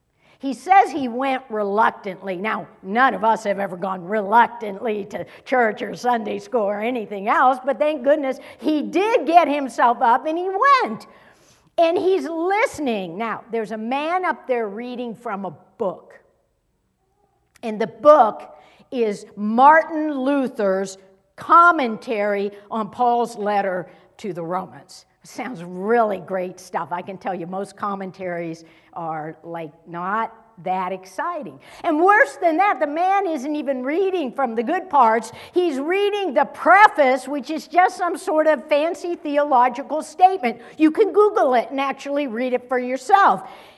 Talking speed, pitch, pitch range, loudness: 150 wpm, 245 Hz, 205-310 Hz, -20 LUFS